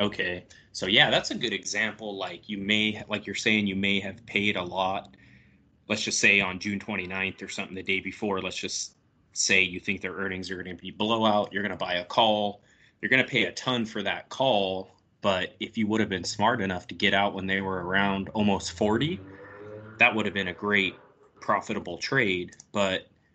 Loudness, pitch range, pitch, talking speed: -26 LUFS, 95-105 Hz, 100 Hz, 215 wpm